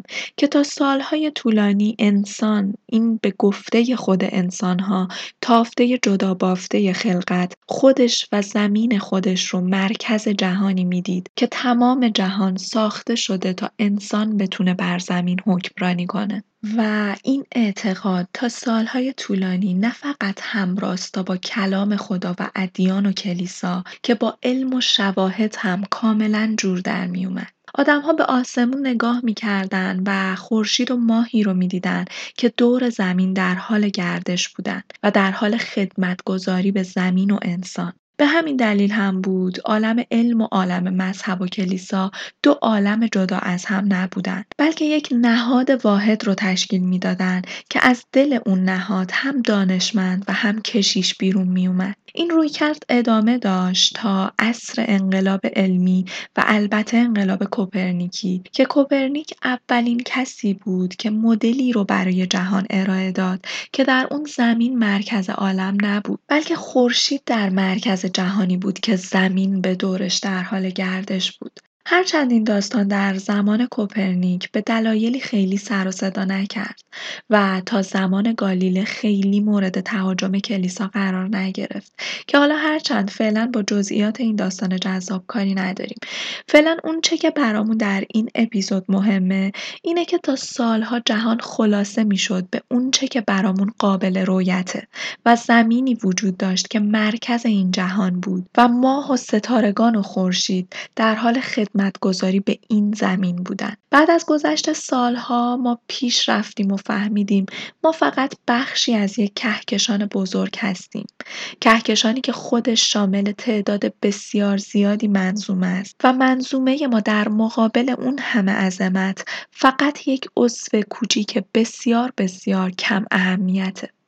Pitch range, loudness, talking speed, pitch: 190-235 Hz, -19 LUFS, 140 wpm, 210 Hz